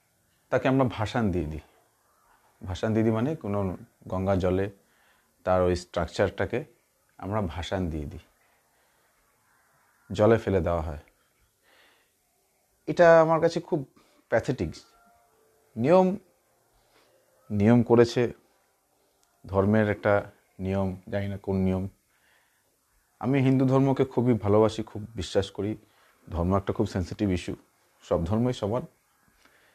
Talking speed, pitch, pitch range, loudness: 110 wpm, 105 Hz, 95-120 Hz, -26 LUFS